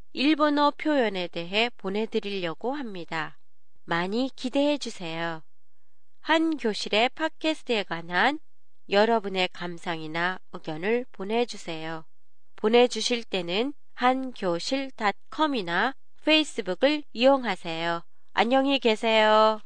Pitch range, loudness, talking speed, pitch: 180-265 Hz, -26 LUFS, 250 characters per minute, 220 Hz